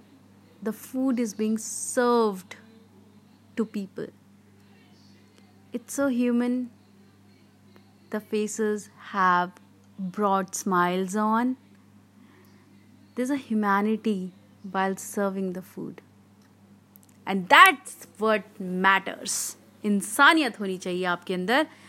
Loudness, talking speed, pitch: -25 LUFS, 90 wpm, 195 Hz